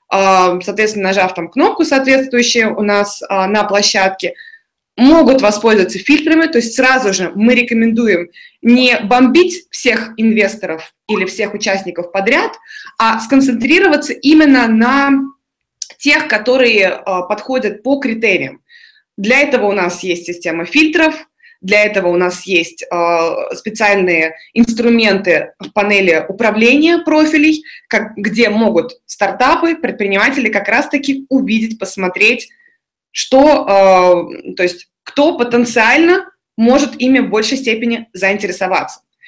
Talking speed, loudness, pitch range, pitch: 110 wpm, -12 LUFS, 195-275 Hz, 230 Hz